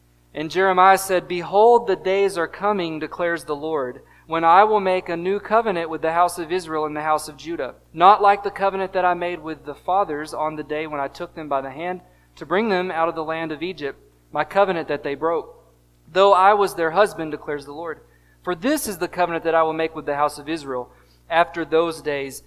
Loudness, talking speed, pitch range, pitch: -21 LUFS, 230 wpm, 150-185 Hz, 165 Hz